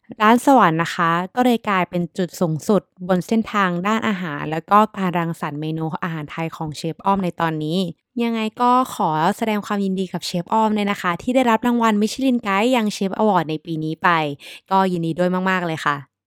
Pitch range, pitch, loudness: 165-215 Hz, 185 Hz, -20 LUFS